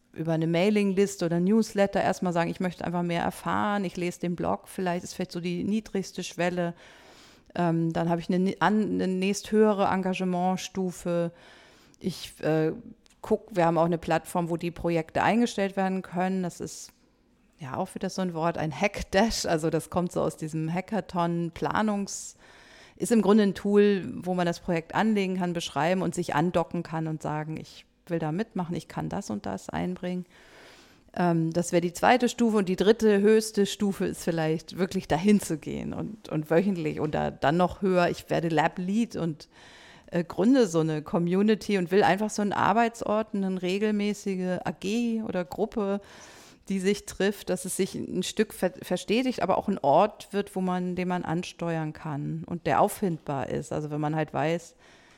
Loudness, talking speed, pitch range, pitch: -27 LUFS, 185 wpm, 170-200 Hz, 180 Hz